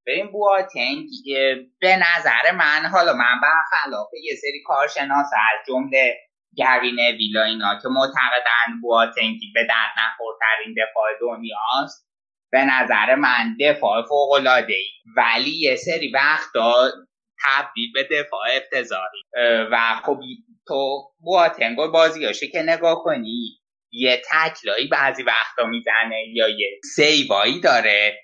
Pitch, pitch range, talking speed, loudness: 135 Hz, 115-175 Hz, 125 wpm, -19 LUFS